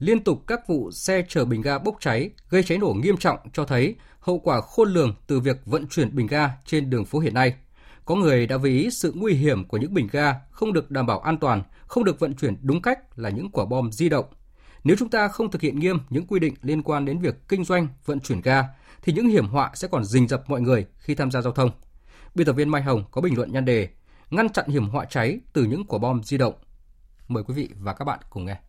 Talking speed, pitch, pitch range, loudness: 260 wpm, 140 Hz, 125-165 Hz, -23 LUFS